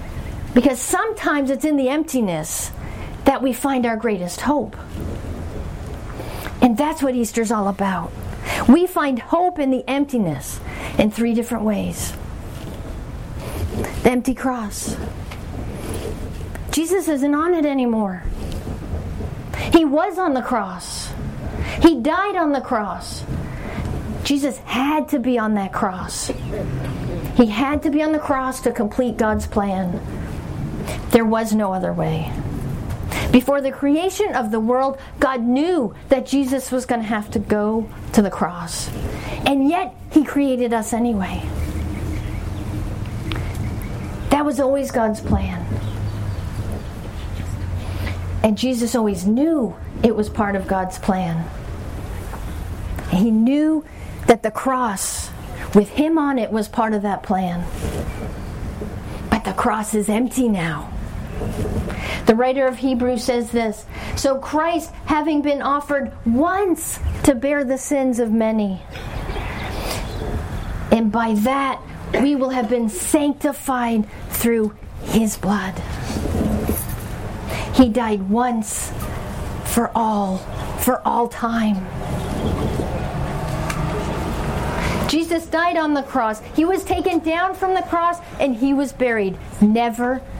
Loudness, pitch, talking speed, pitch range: -21 LUFS, 235 Hz, 120 wpm, 175-275 Hz